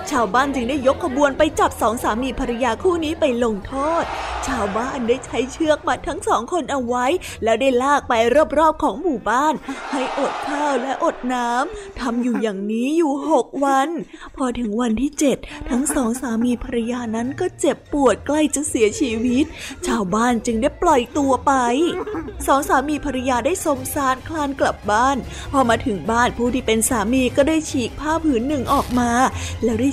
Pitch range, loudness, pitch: 245-300 Hz, -20 LUFS, 270 Hz